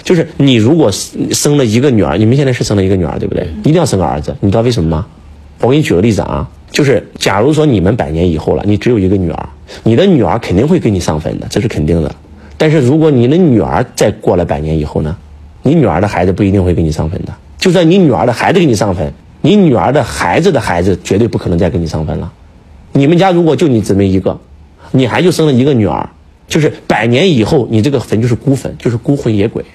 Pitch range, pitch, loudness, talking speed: 85-130 Hz, 105 Hz, -11 LUFS, 375 characters per minute